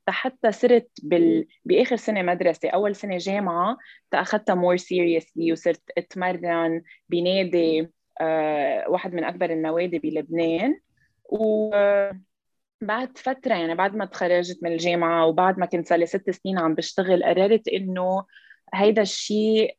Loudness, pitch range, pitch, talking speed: -23 LUFS, 170-210 Hz, 180 Hz, 125 wpm